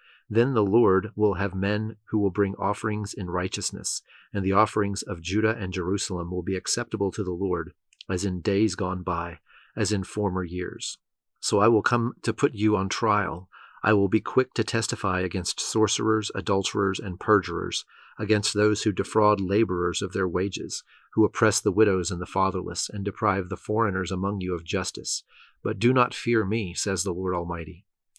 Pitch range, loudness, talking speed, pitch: 95-110 Hz, -26 LUFS, 185 wpm, 100 Hz